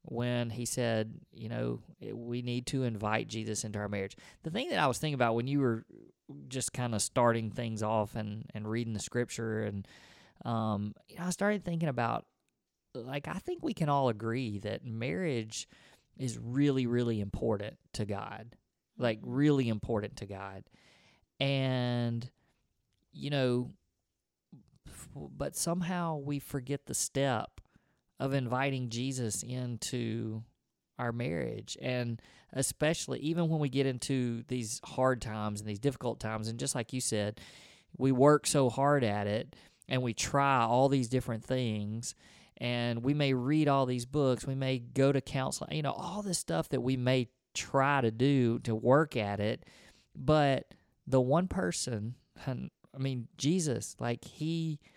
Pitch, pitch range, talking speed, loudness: 125 Hz, 115-140 Hz, 160 wpm, -33 LUFS